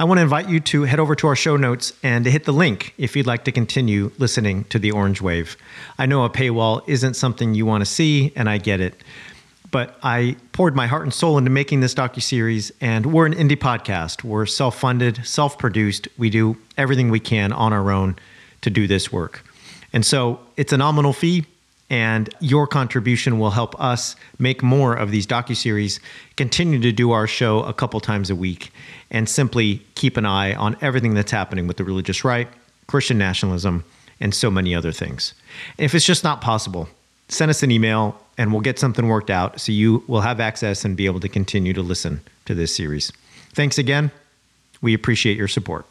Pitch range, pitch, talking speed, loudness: 105-135 Hz, 120 Hz, 205 wpm, -19 LUFS